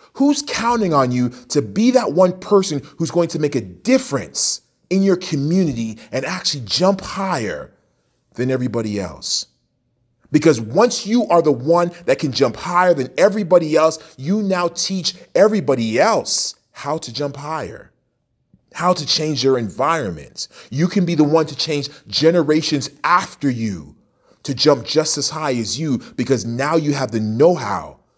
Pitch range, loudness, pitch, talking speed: 130-175 Hz, -18 LUFS, 155 Hz, 160 wpm